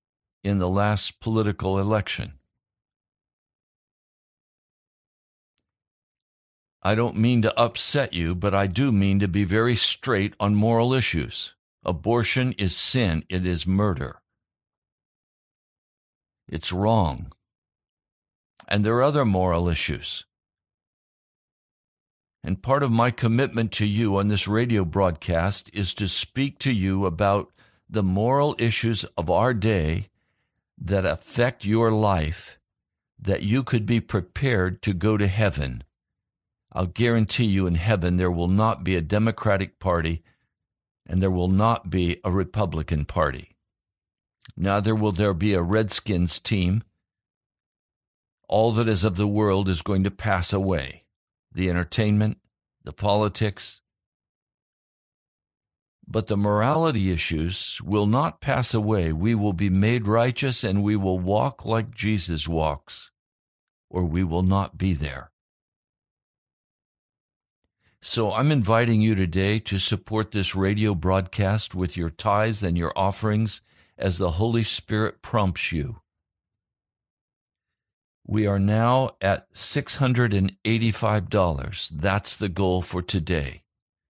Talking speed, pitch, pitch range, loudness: 125 wpm, 100 Hz, 90-110 Hz, -23 LUFS